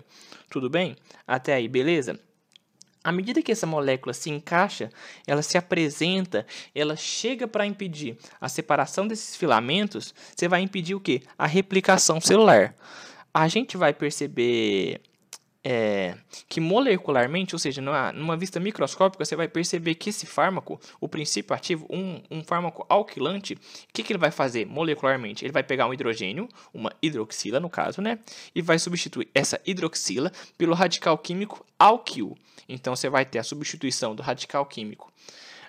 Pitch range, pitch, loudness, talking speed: 140-190 Hz, 165 Hz, -25 LUFS, 155 wpm